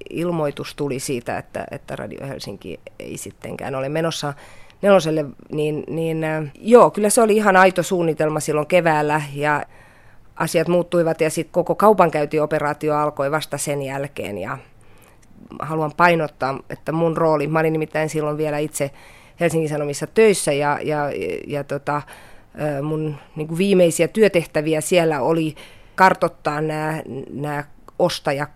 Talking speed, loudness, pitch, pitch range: 135 wpm, -20 LUFS, 155 Hz, 145-170 Hz